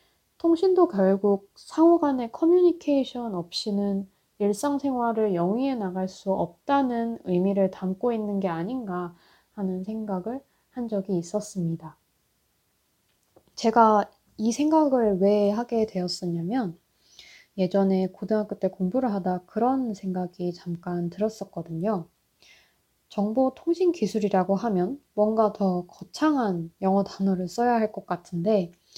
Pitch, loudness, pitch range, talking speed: 205 Hz, -25 LUFS, 185-240 Hz, 260 characters per minute